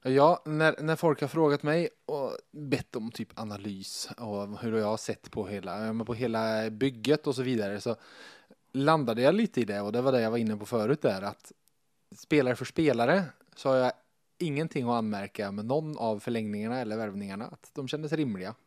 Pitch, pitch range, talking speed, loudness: 125 Hz, 110-150 Hz, 195 wpm, -30 LUFS